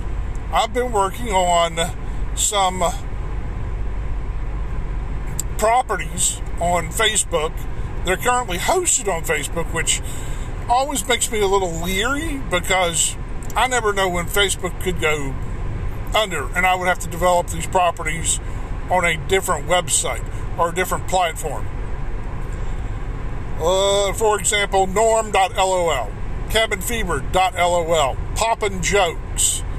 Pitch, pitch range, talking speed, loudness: 180 Hz, 135-200 Hz, 105 wpm, -20 LUFS